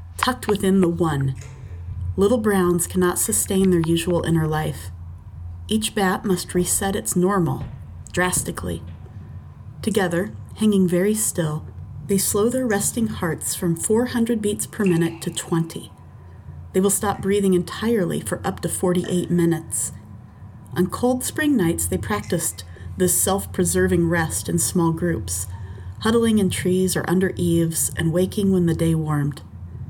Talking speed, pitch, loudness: 140 wpm, 170 Hz, -21 LUFS